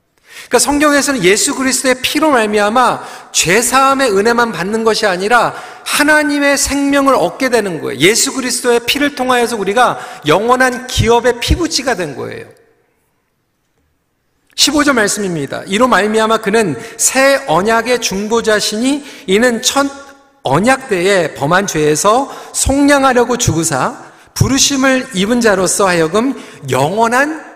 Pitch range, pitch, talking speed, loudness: 215-275 Hz, 245 Hz, 300 characters per minute, -12 LUFS